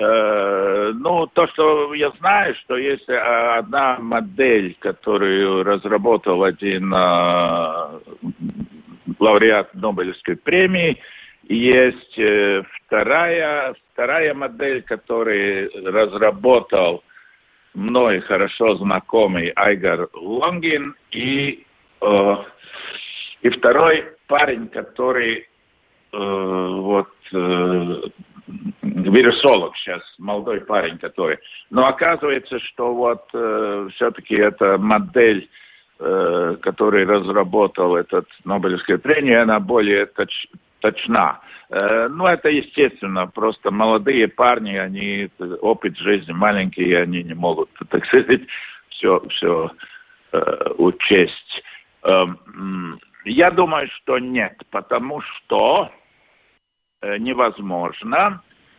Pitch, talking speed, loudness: 115 Hz, 90 wpm, -18 LUFS